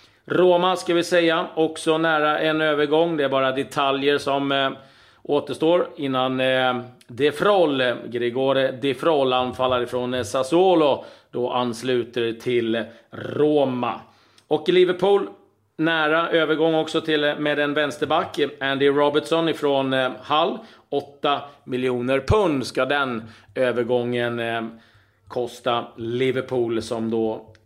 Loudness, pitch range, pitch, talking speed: -22 LUFS, 120-155 Hz, 135 Hz, 120 wpm